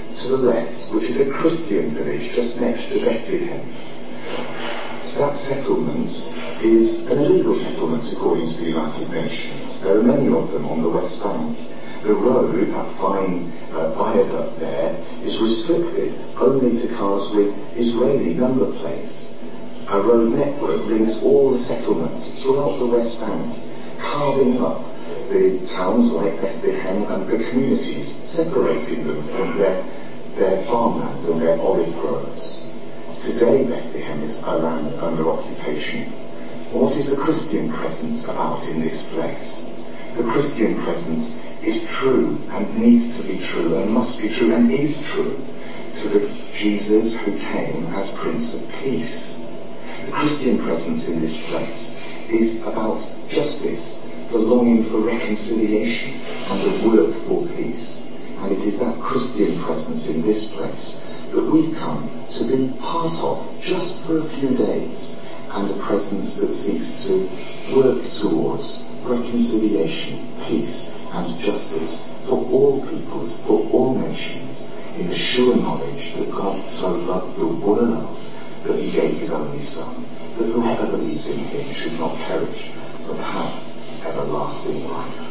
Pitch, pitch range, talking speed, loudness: 110 Hz, 80-125 Hz, 145 wpm, -21 LUFS